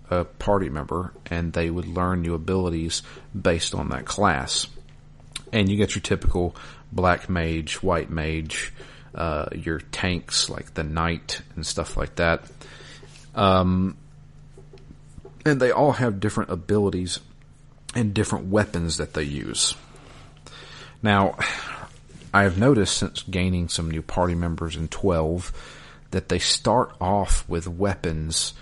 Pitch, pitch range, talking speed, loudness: 90 Hz, 80-100 Hz, 130 wpm, -24 LUFS